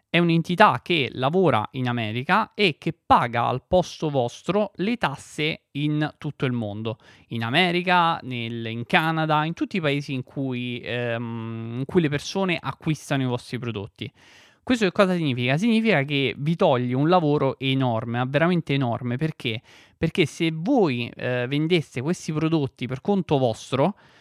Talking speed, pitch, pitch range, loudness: 155 wpm, 145 Hz, 125-175 Hz, -23 LUFS